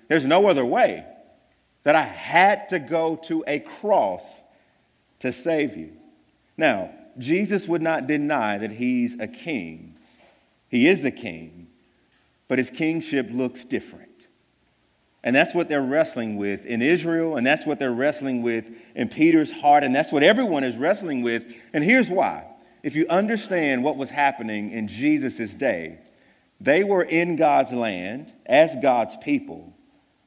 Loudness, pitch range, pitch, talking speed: -22 LUFS, 120-180 Hz, 150 Hz, 155 wpm